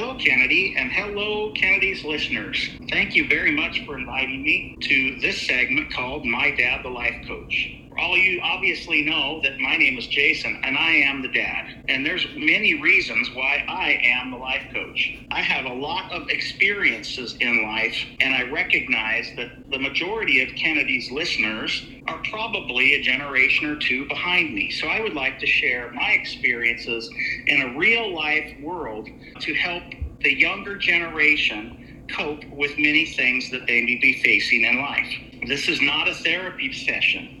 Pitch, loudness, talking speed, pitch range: 130 Hz, -20 LUFS, 170 wpm, 125-150 Hz